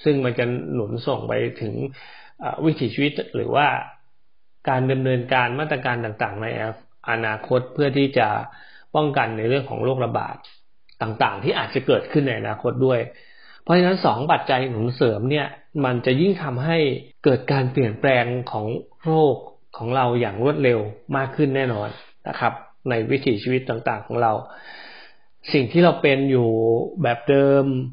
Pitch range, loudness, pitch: 120-145 Hz, -21 LUFS, 130 Hz